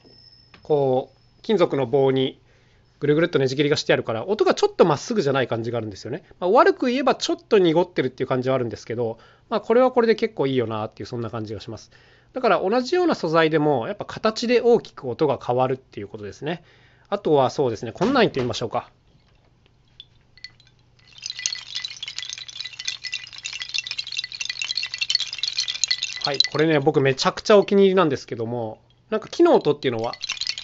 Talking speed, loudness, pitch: 380 characters per minute, -22 LUFS, 135 Hz